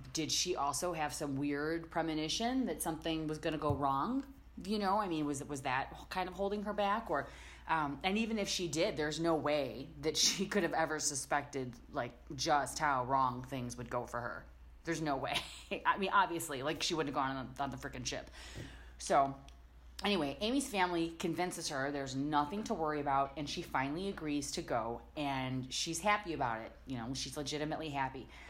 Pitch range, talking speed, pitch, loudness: 135-175 Hz, 200 wpm, 150 Hz, -36 LUFS